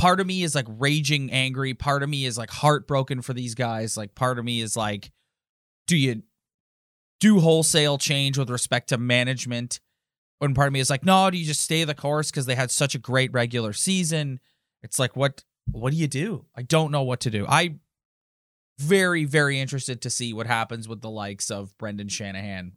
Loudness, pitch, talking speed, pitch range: -23 LUFS, 130 Hz, 210 wpm, 115-150 Hz